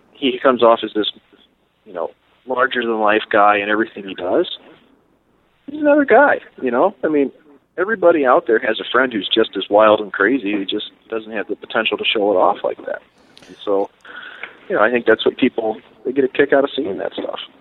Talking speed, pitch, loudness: 220 wpm, 125 Hz, -17 LUFS